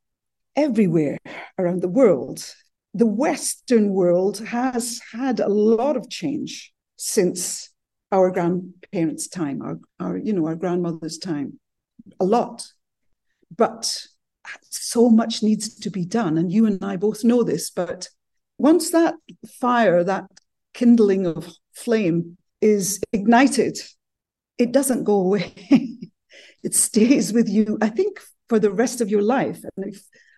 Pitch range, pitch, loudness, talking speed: 190-240 Hz, 215 Hz, -21 LUFS, 135 wpm